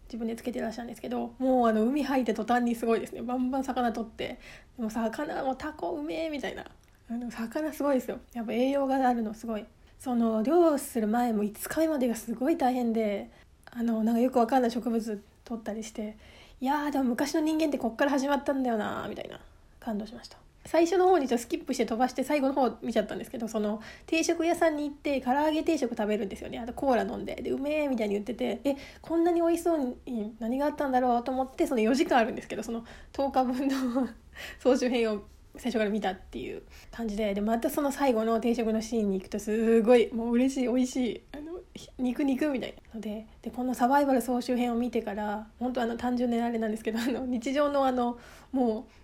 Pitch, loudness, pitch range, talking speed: 245 Hz, -29 LUFS, 230-280 Hz, 440 characters per minute